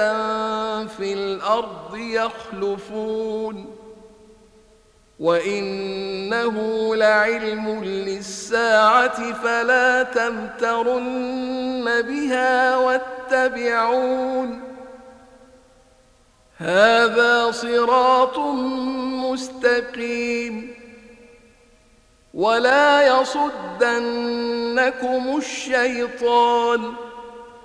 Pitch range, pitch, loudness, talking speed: 220-255 Hz, 235 Hz, -20 LUFS, 35 wpm